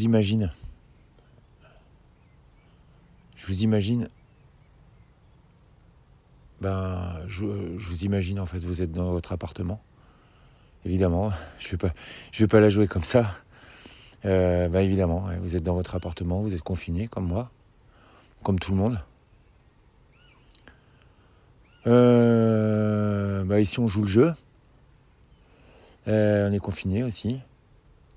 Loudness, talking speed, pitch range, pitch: -25 LUFS, 120 wpm, 90-115 Hz, 100 Hz